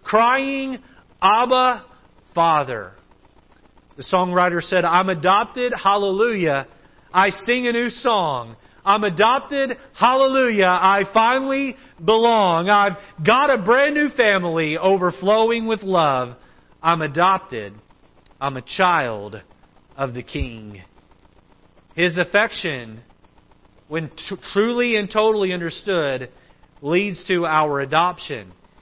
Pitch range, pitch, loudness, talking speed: 155-225 Hz, 190 Hz, -19 LUFS, 100 wpm